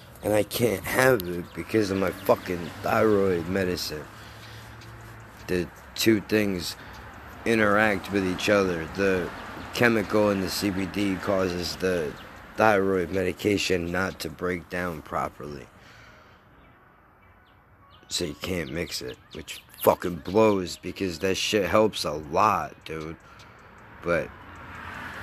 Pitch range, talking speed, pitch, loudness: 90-110 Hz, 115 wpm, 95 Hz, -26 LUFS